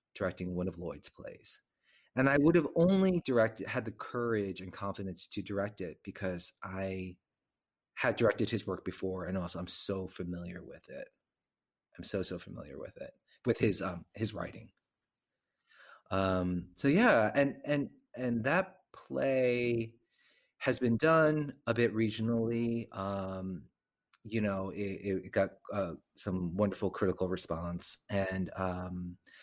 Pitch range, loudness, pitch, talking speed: 95-115 Hz, -33 LUFS, 100 Hz, 145 wpm